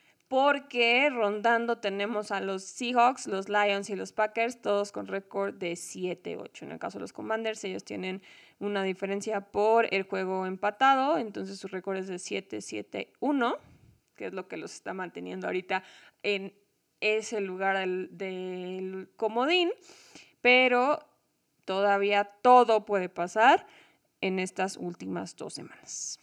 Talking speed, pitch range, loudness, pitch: 135 wpm, 190-230 Hz, -29 LUFS, 200 Hz